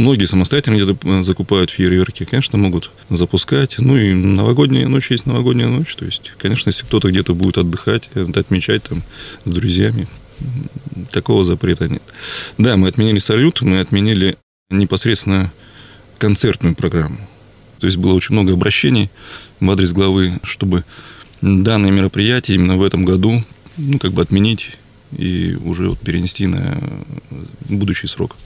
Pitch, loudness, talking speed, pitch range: 100 Hz, -15 LUFS, 140 wpm, 95-120 Hz